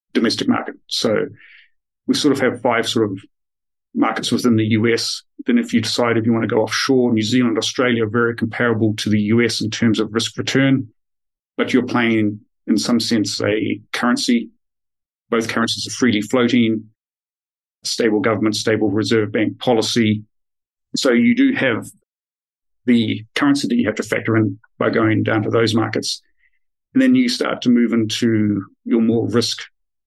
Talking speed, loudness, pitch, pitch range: 170 wpm, -18 LUFS, 115 Hz, 110-125 Hz